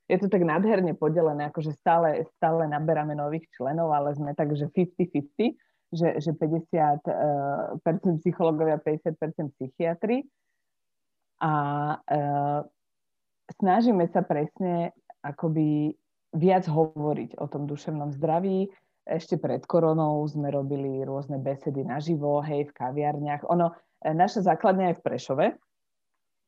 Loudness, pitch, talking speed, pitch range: -27 LUFS, 160 Hz, 115 wpm, 145-170 Hz